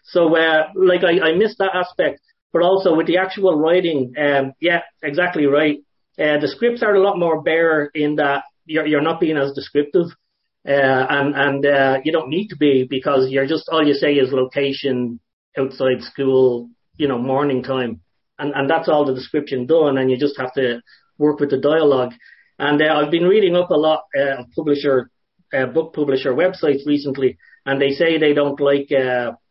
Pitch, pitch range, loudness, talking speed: 145 Hz, 135-165 Hz, -18 LUFS, 195 wpm